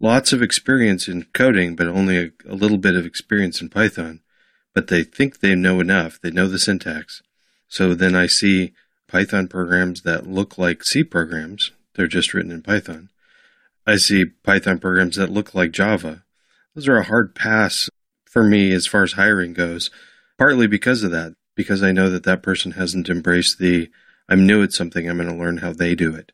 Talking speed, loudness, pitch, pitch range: 195 wpm, -18 LUFS, 90 Hz, 85-95 Hz